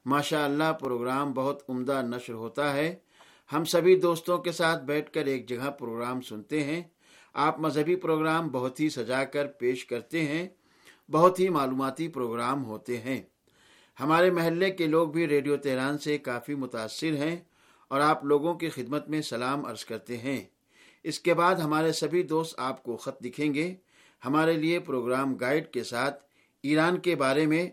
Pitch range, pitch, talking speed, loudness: 130-160 Hz, 145 Hz, 170 wpm, -28 LUFS